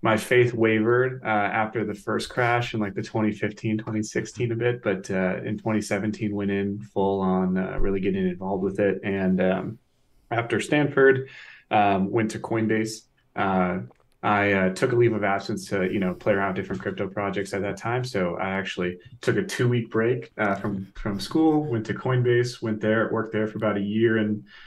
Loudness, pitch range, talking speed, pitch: -25 LUFS, 100-115 Hz, 195 wpm, 105 Hz